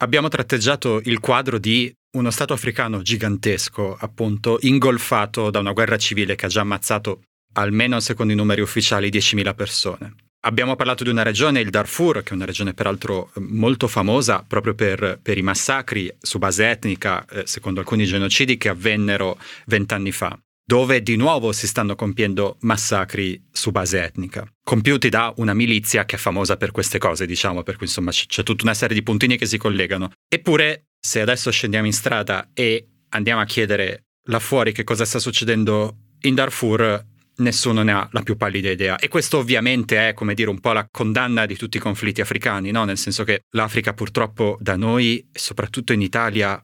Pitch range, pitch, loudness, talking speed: 105-120 Hz, 110 Hz, -20 LUFS, 180 wpm